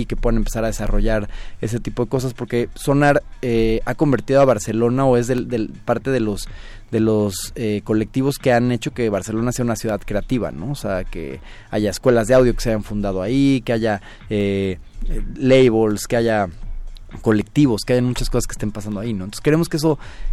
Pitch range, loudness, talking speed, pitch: 105-125 Hz, -20 LUFS, 205 wpm, 115 Hz